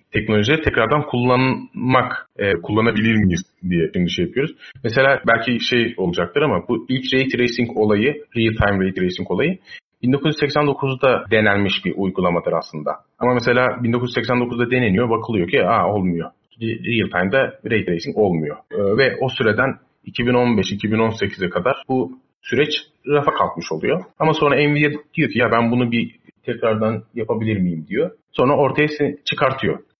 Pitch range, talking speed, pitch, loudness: 110-130 Hz, 135 wpm, 120 Hz, -19 LUFS